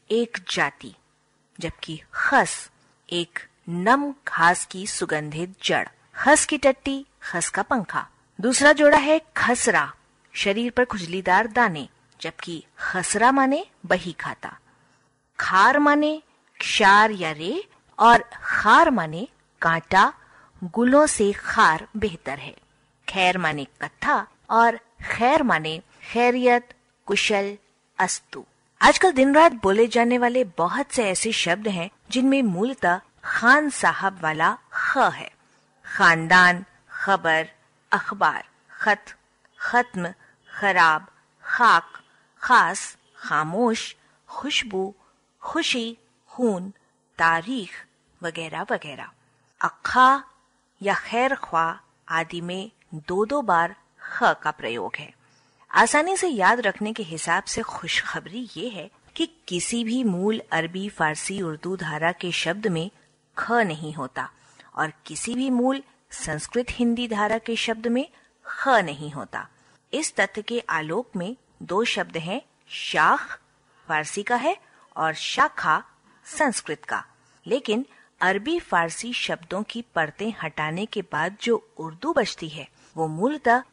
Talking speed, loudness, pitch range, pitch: 120 wpm, -22 LUFS, 165-245 Hz, 205 Hz